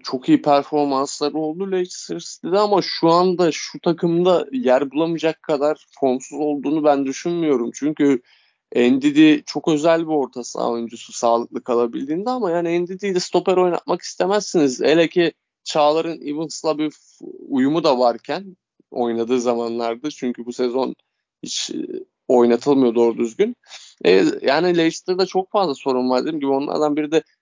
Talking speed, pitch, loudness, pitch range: 135 wpm, 155 Hz, -19 LUFS, 135-185 Hz